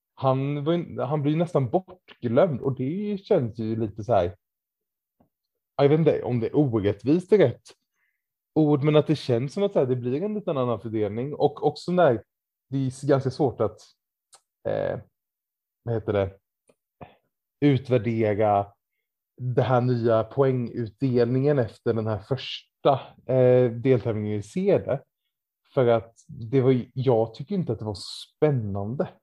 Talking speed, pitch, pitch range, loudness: 150 wpm, 130 Hz, 115-150 Hz, -24 LUFS